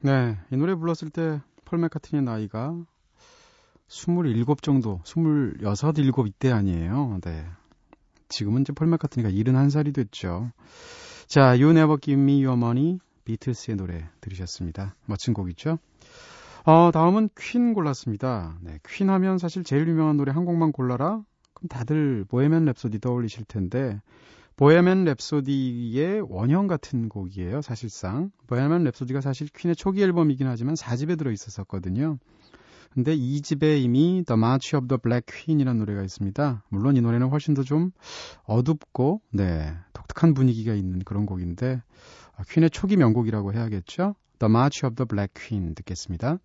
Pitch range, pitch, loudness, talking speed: 110-160 Hz, 135 Hz, -24 LUFS, 360 characters per minute